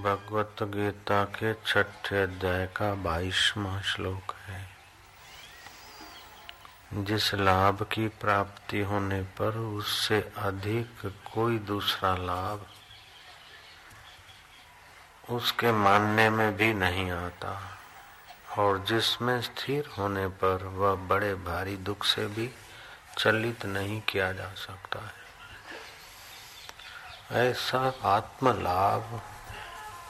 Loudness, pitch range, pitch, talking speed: -29 LUFS, 95-110 Hz, 100 Hz, 90 wpm